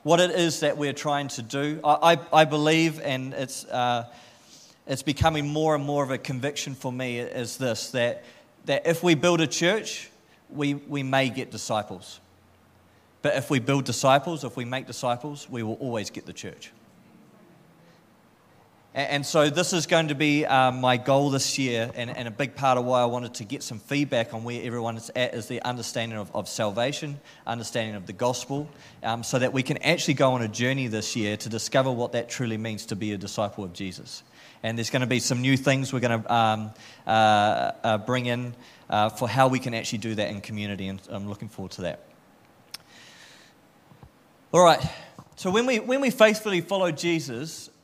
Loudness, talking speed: -25 LUFS, 200 wpm